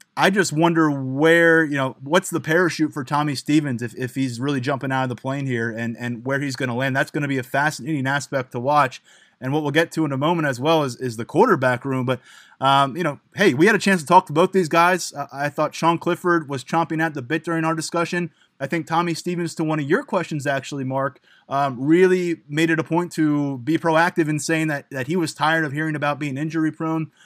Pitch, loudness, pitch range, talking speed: 155 Hz, -21 LUFS, 135-165 Hz, 250 wpm